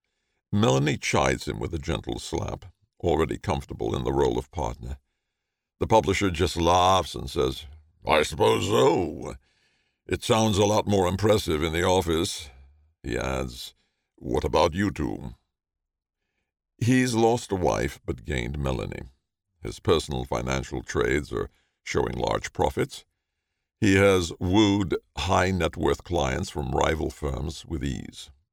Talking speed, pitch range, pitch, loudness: 135 wpm, 70-100 Hz, 85 Hz, -25 LUFS